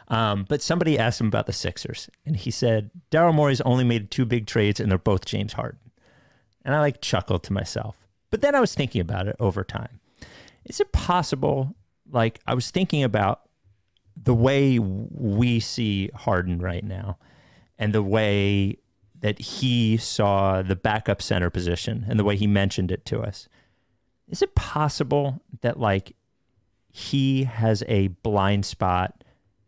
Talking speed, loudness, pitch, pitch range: 165 wpm, -24 LUFS, 110 Hz, 100-130 Hz